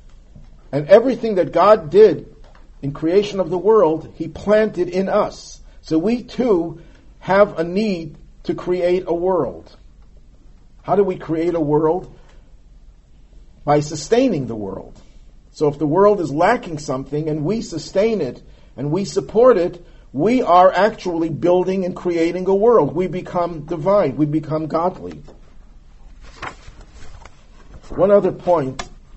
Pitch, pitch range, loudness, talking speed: 175 Hz, 155-195 Hz, -18 LUFS, 135 wpm